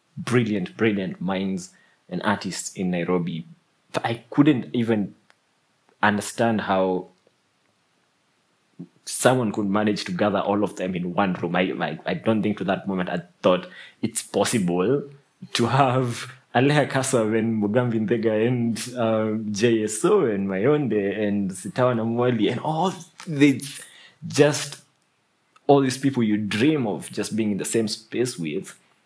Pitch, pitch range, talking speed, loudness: 110 Hz, 100-130 Hz, 140 wpm, -23 LUFS